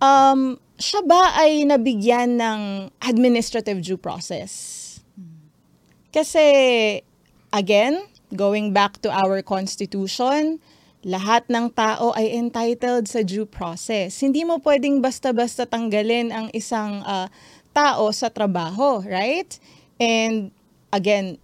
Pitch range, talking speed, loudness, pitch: 200-260 Hz, 105 wpm, -20 LUFS, 225 Hz